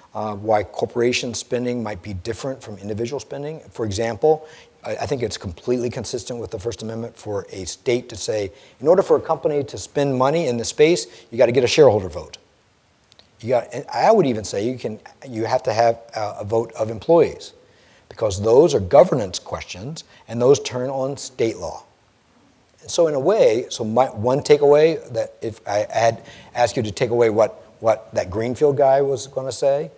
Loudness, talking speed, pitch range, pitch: -20 LUFS, 195 wpm, 115-140 Hz, 120 Hz